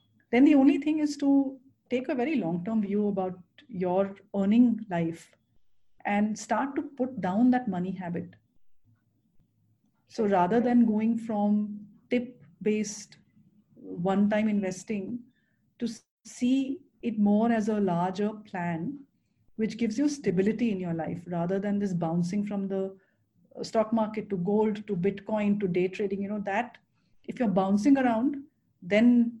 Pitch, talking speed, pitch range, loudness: 210 Hz, 145 wpm, 195-235 Hz, -28 LUFS